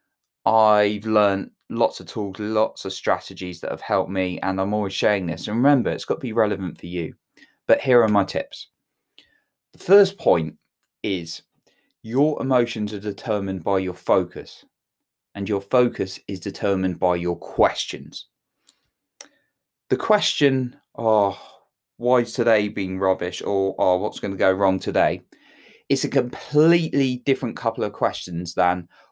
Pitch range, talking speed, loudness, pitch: 95-125 Hz, 150 wpm, -22 LUFS, 105 Hz